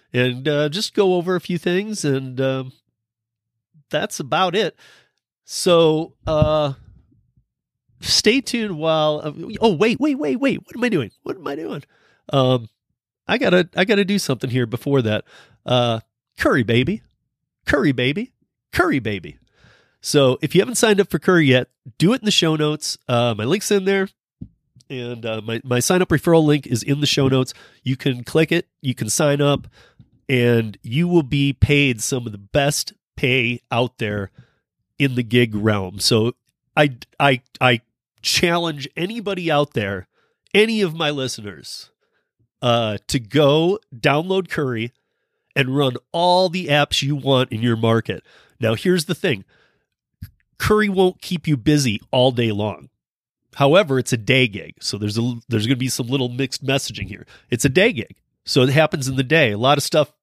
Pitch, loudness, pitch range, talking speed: 140 Hz, -19 LUFS, 120-165 Hz, 180 wpm